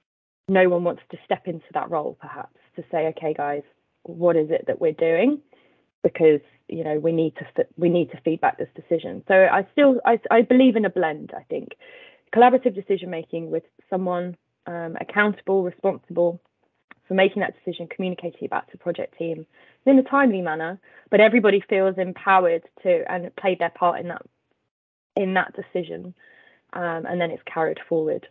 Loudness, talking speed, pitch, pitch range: -22 LUFS, 180 wpm, 180 Hz, 165-210 Hz